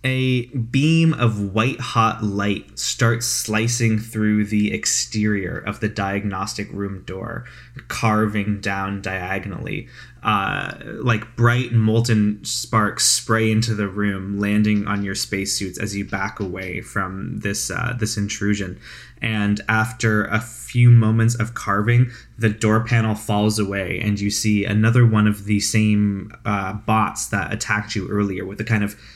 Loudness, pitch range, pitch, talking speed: -20 LUFS, 100-115 Hz, 105 Hz, 145 wpm